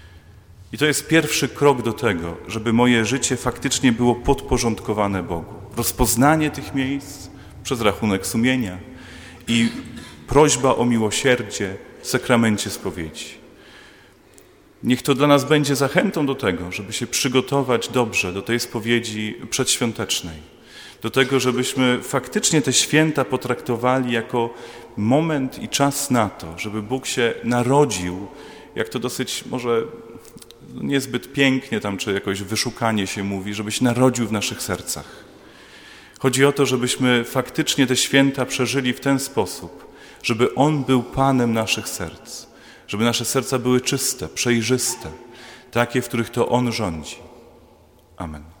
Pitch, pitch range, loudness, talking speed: 120 Hz, 110-135 Hz, -20 LUFS, 130 wpm